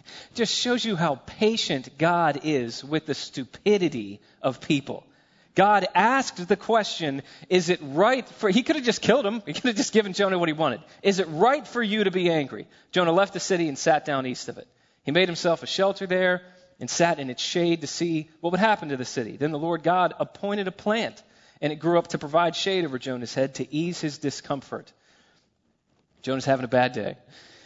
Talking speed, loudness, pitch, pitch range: 215 wpm, -25 LUFS, 170 Hz, 140-195 Hz